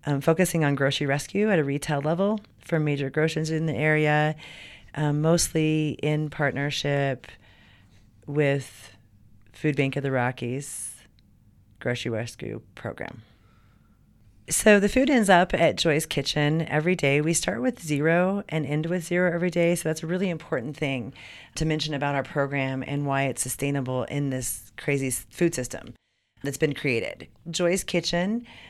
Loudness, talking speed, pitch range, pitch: -25 LUFS, 155 wpm, 130-160 Hz, 145 Hz